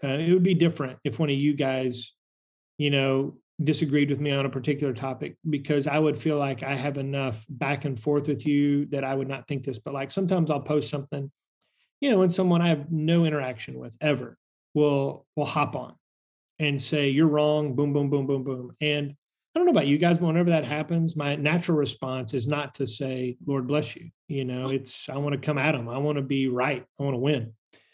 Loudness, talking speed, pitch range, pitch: -26 LUFS, 230 wpm, 135-150 Hz, 145 Hz